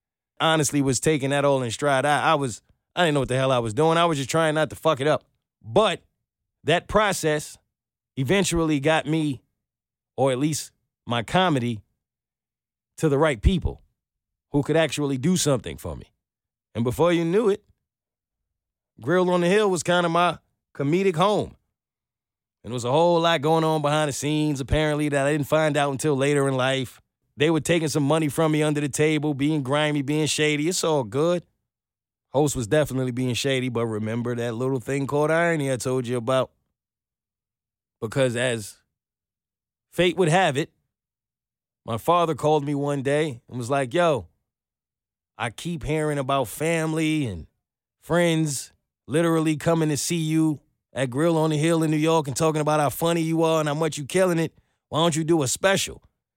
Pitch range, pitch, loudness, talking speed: 130-160 Hz, 150 Hz, -23 LUFS, 185 wpm